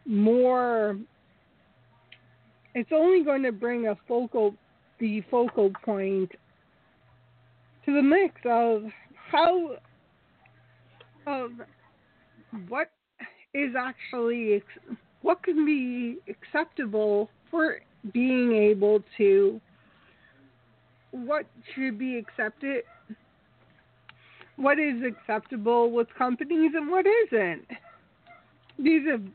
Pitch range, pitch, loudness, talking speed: 210-285 Hz, 240 Hz, -26 LUFS, 85 wpm